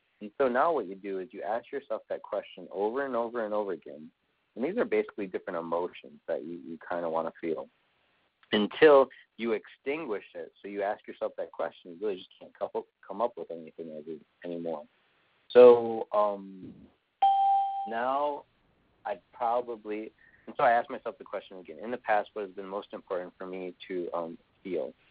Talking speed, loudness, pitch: 185 wpm, -29 LUFS, 120 Hz